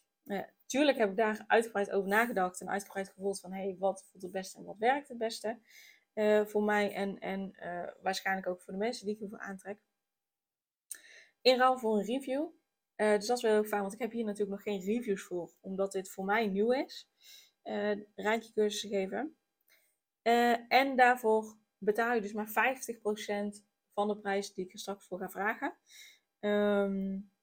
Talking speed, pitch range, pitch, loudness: 195 wpm, 195-225 Hz, 210 Hz, -33 LUFS